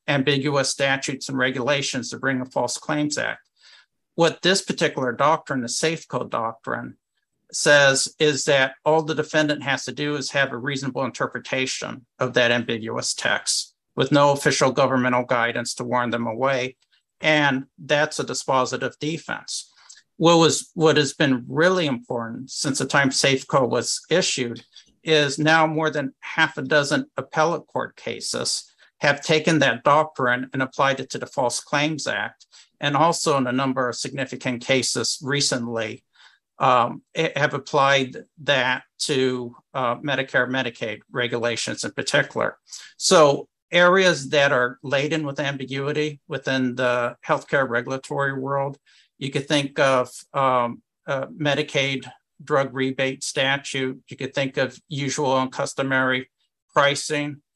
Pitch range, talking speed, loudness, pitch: 130-150 Hz, 140 wpm, -22 LUFS, 135 Hz